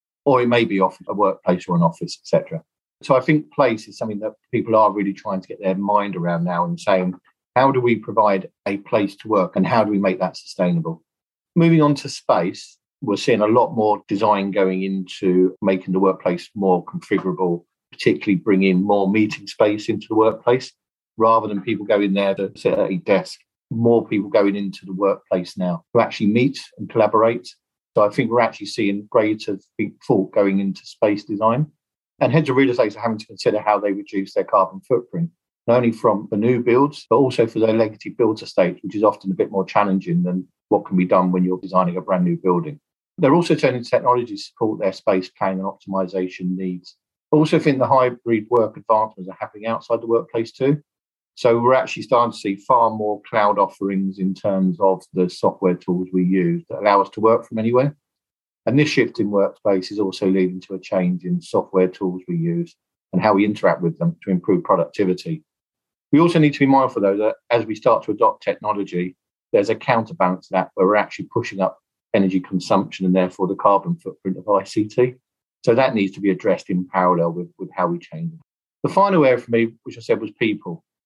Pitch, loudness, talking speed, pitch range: 100 Hz, -20 LUFS, 210 wpm, 95-125 Hz